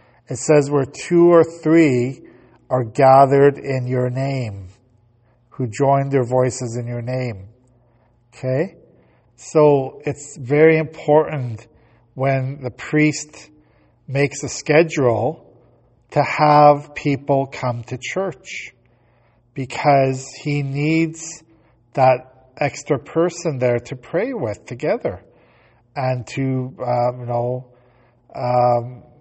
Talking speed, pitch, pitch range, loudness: 105 wpm, 130 Hz, 120-145 Hz, -18 LUFS